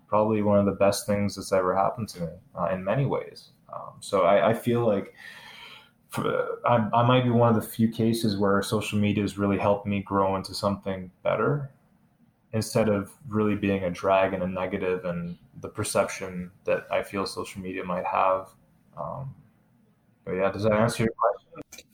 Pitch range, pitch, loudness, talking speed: 95-115 Hz, 100 Hz, -26 LUFS, 190 wpm